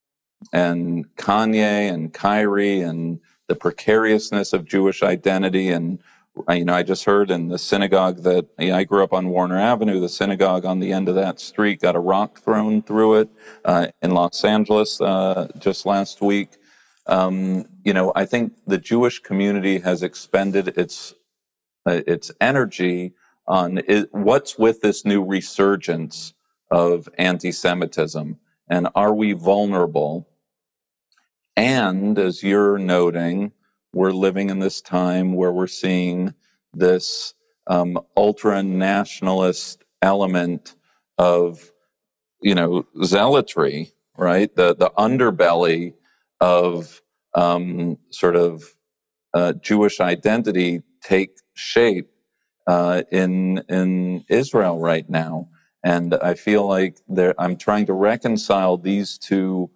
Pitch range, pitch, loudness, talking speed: 90-100 Hz, 95 Hz, -20 LUFS, 130 wpm